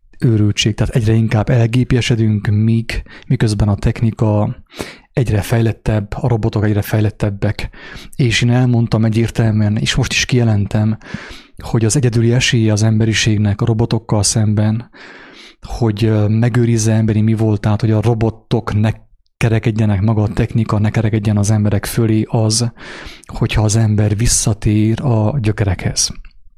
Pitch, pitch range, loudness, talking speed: 110 Hz, 105-115 Hz, -15 LUFS, 125 wpm